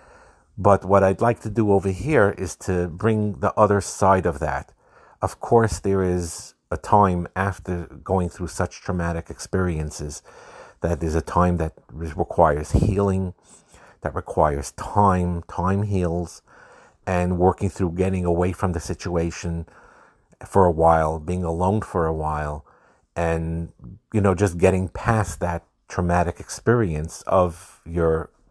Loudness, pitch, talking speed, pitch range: -22 LUFS, 90 Hz, 140 wpm, 85-95 Hz